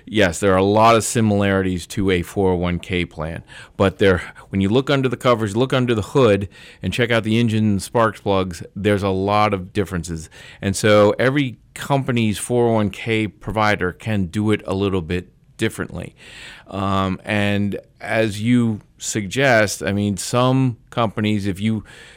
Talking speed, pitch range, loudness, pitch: 160 wpm, 95-115 Hz, -19 LUFS, 105 Hz